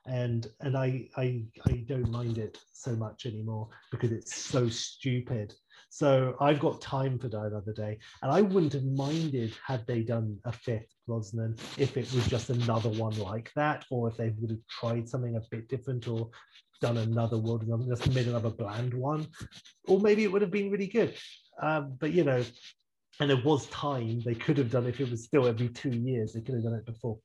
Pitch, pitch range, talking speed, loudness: 120 Hz, 115-135 Hz, 205 wpm, -31 LUFS